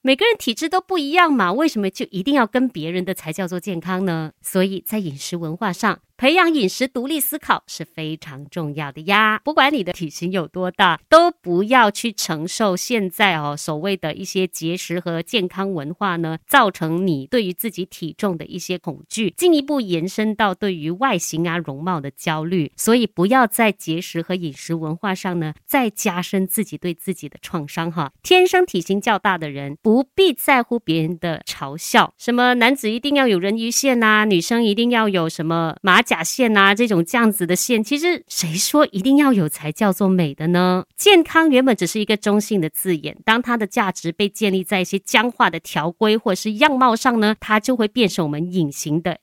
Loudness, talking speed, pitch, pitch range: -19 LUFS, 300 characters per minute, 195 Hz, 170-235 Hz